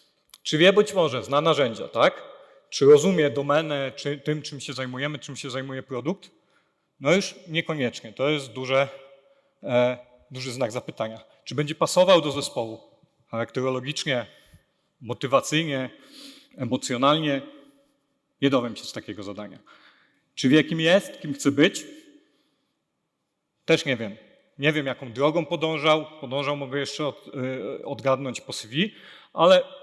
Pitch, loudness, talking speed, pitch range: 145 Hz, -24 LUFS, 135 wpm, 130-170 Hz